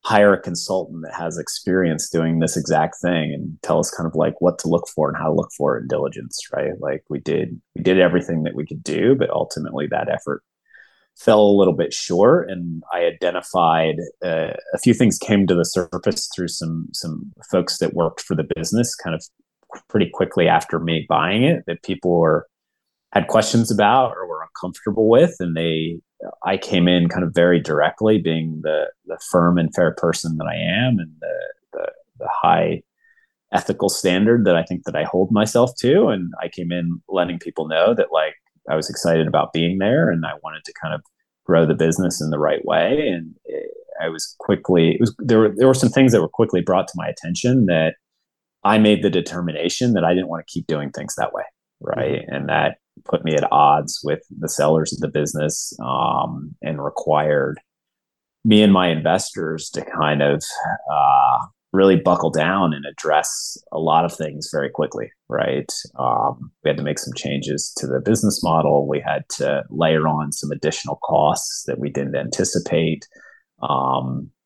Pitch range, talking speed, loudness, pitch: 80-105 Hz, 195 wpm, -19 LUFS, 85 Hz